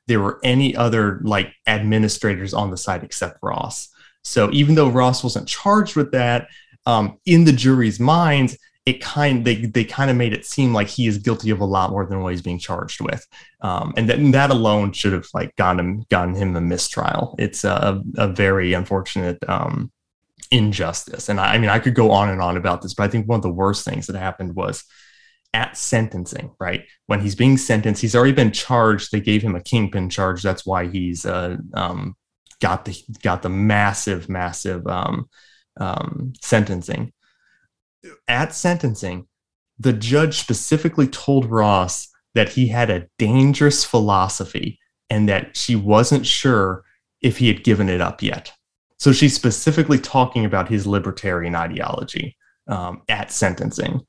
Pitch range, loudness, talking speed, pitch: 95-125 Hz, -19 LUFS, 180 wpm, 110 Hz